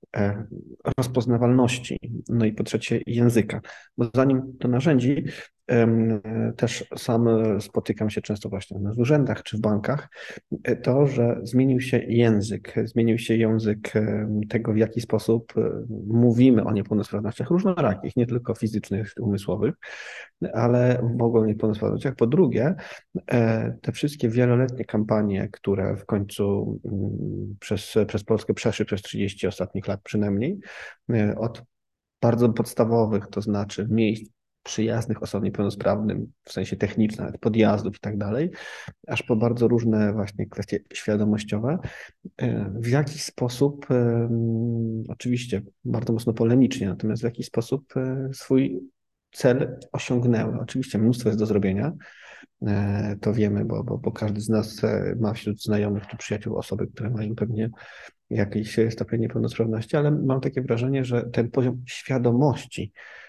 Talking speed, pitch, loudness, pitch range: 125 wpm, 115 Hz, -24 LUFS, 105-125 Hz